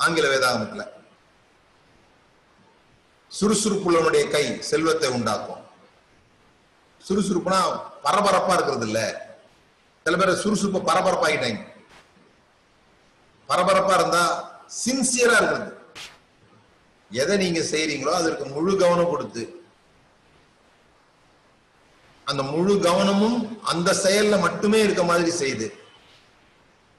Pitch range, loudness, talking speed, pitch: 170-210 Hz, -22 LUFS, 75 wpm, 190 Hz